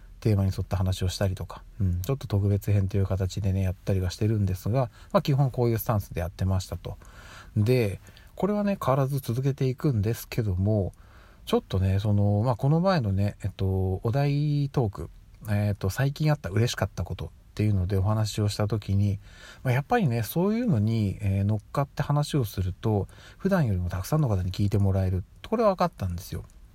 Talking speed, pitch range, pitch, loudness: 415 characters per minute, 95-130 Hz, 105 Hz, -27 LUFS